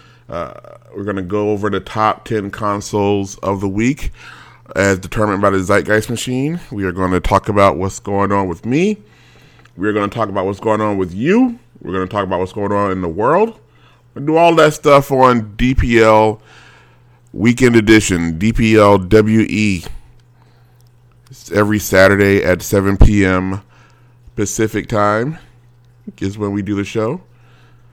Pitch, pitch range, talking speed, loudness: 105 Hz, 100-120 Hz, 160 wpm, -15 LUFS